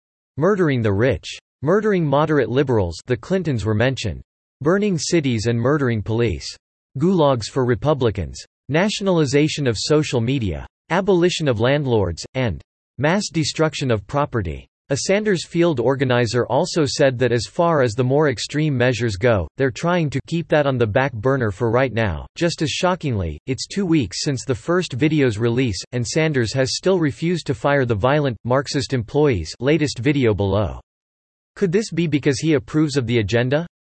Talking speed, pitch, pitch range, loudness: 160 wpm, 135 Hz, 115-155 Hz, -20 LUFS